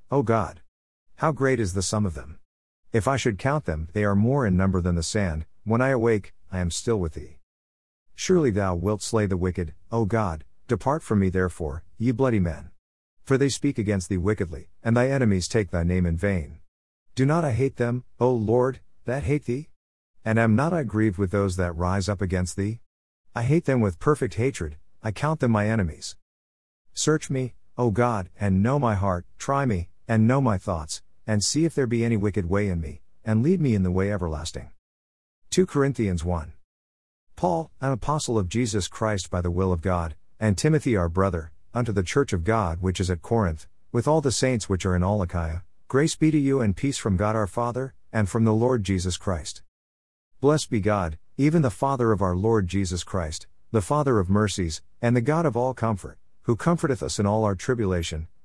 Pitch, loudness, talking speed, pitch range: 100 Hz, -25 LUFS, 210 wpm, 90-120 Hz